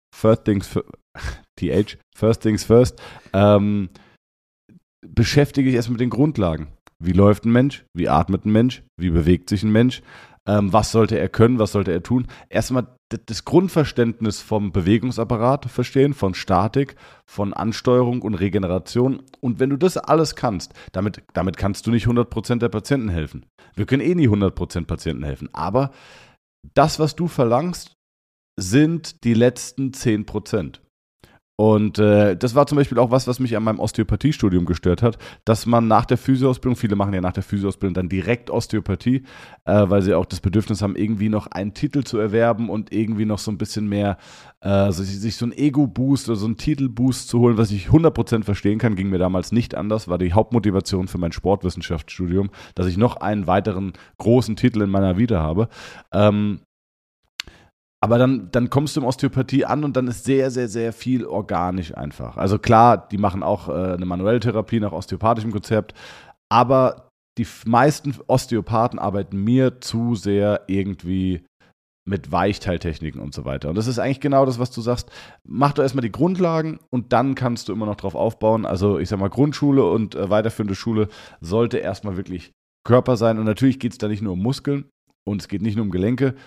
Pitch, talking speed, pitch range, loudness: 110 Hz, 185 wpm, 100-125 Hz, -20 LUFS